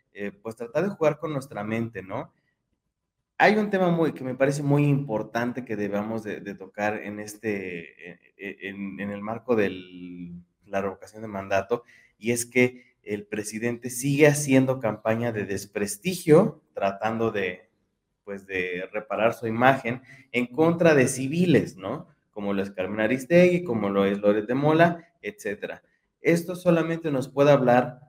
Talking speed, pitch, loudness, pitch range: 155 wpm, 115 Hz, -25 LUFS, 100-145 Hz